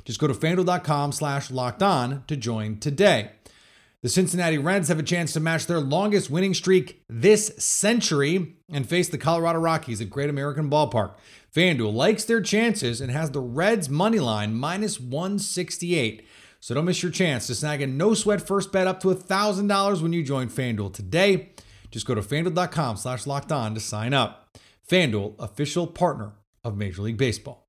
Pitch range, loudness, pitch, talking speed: 125-185 Hz, -24 LUFS, 155 Hz, 180 wpm